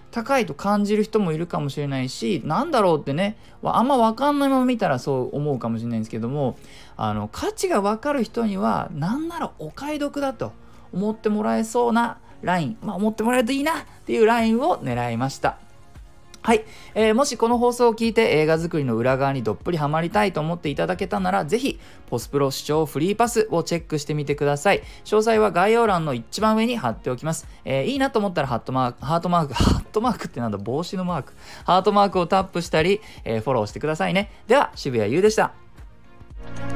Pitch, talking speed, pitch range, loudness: 180 Hz, 450 characters per minute, 140-225 Hz, -22 LUFS